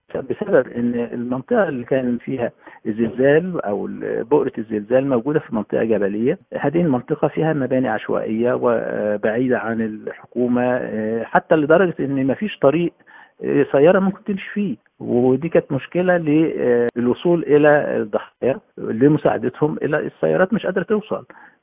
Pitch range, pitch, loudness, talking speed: 120-160 Hz, 130 Hz, -19 LUFS, 120 wpm